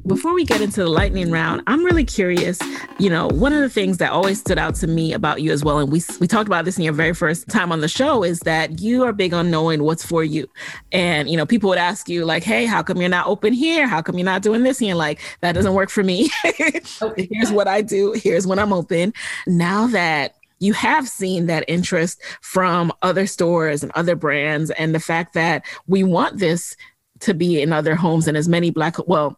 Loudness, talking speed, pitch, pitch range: -19 LUFS, 240 wpm, 175 Hz, 160-205 Hz